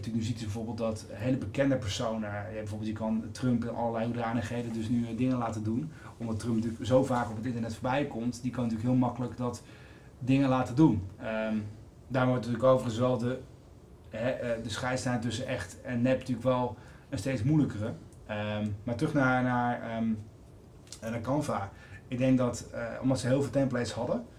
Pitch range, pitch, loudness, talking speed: 110-125 Hz, 120 Hz, -31 LUFS, 185 wpm